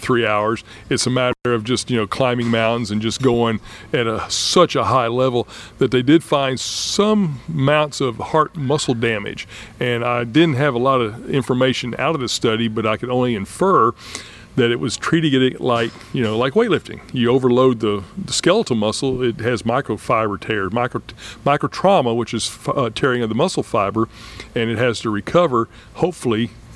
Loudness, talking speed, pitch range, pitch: -18 LUFS, 190 wpm, 115-130 Hz, 120 Hz